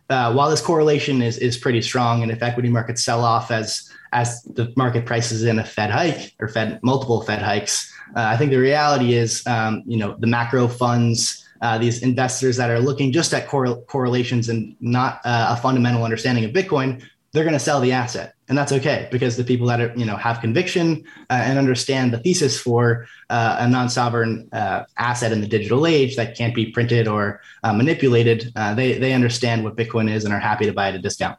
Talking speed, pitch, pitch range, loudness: 215 wpm, 120 Hz, 115-130 Hz, -20 LUFS